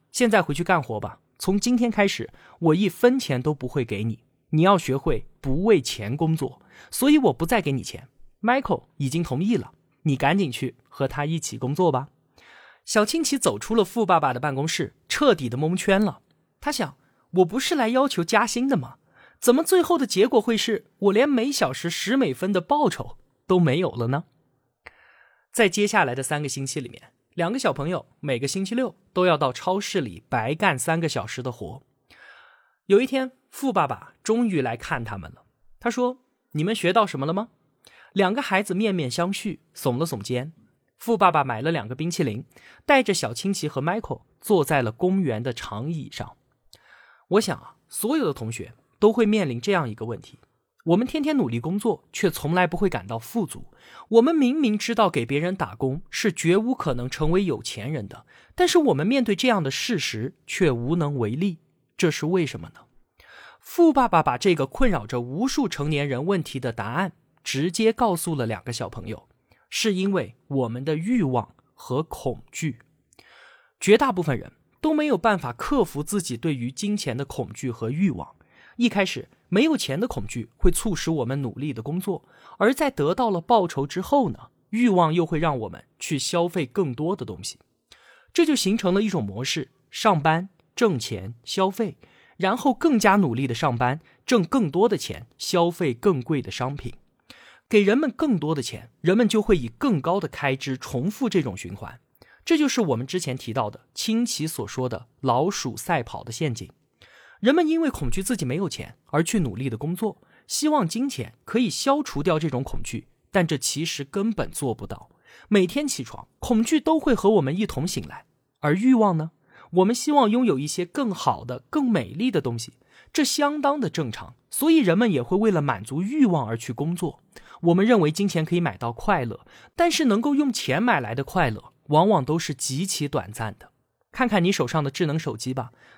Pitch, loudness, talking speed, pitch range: 170 Hz, -24 LUFS, 275 characters per minute, 135-220 Hz